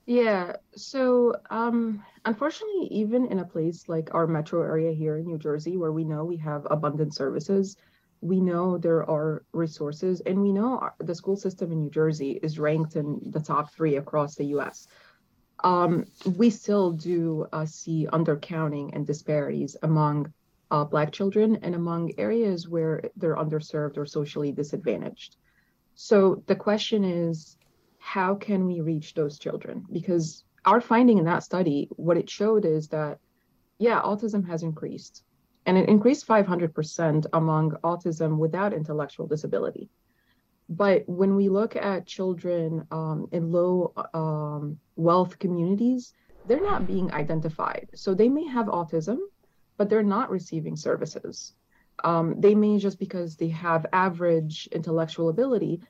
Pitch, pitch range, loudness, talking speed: 170 Hz, 155-200 Hz, -26 LUFS, 150 wpm